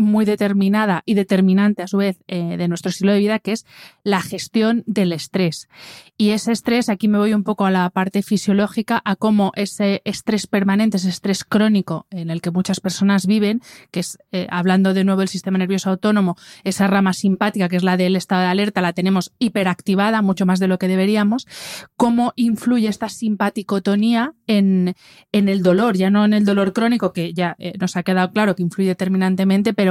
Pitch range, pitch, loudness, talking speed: 185-210 Hz, 195 Hz, -18 LUFS, 200 wpm